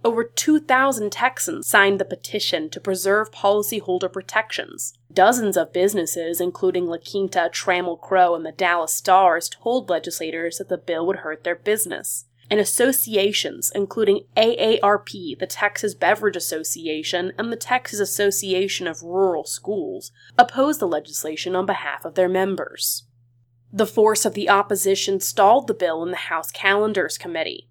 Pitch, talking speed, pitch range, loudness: 195 Hz, 145 wpm, 170-210 Hz, -21 LUFS